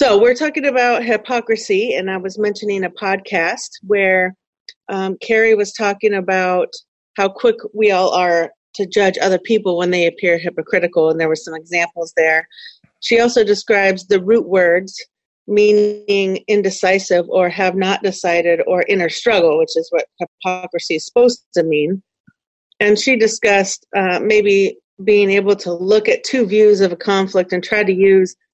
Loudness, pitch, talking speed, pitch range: -15 LUFS, 195 Hz, 165 wpm, 185-220 Hz